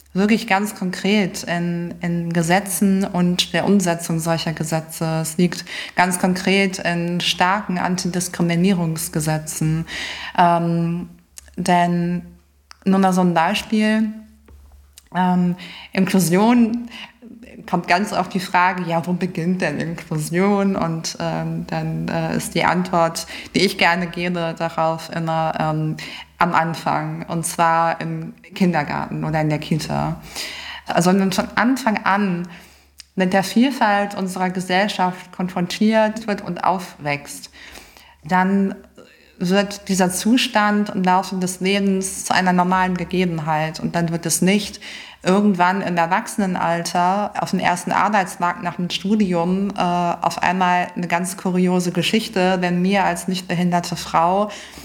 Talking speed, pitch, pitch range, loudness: 125 wpm, 180 Hz, 170-195 Hz, -19 LUFS